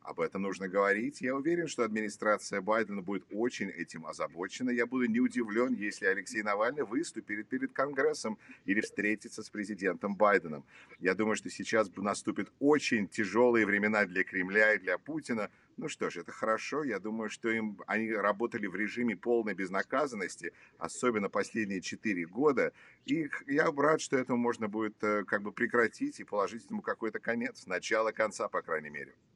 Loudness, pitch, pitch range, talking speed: -32 LUFS, 110 Hz, 105-120 Hz, 165 wpm